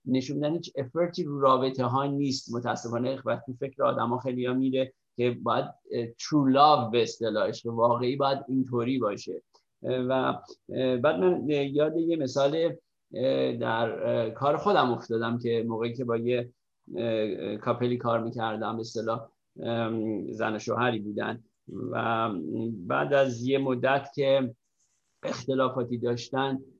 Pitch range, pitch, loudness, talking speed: 115-135 Hz, 125 Hz, -28 LUFS, 125 wpm